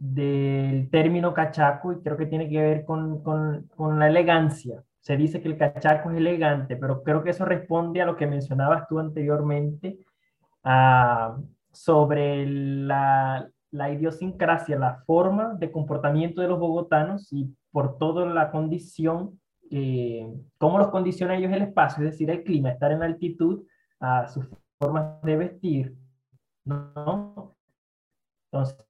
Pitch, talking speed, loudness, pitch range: 155 Hz, 145 wpm, -24 LUFS, 140-165 Hz